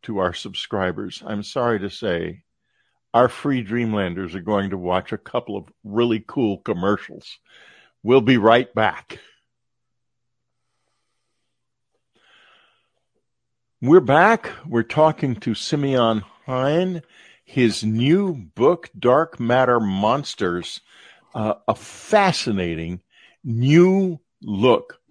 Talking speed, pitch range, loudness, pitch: 100 wpm, 105-135 Hz, -20 LUFS, 120 Hz